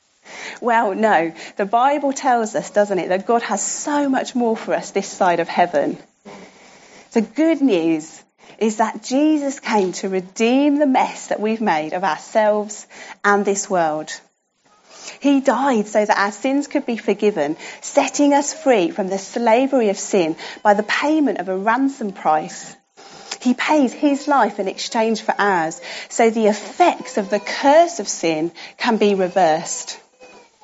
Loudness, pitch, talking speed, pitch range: -19 LUFS, 220 Hz, 160 wpm, 200-270 Hz